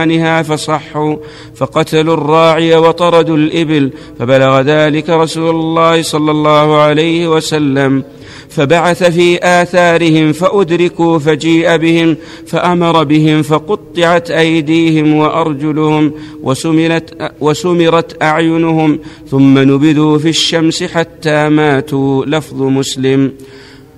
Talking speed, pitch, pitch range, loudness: 85 wpm, 155 Hz, 150-165 Hz, -10 LUFS